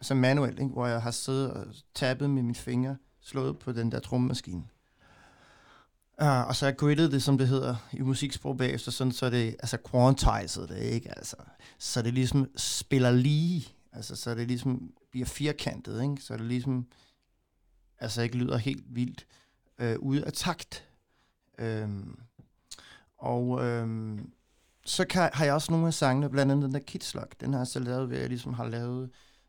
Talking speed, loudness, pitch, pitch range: 180 wpm, -30 LUFS, 125 Hz, 120-135 Hz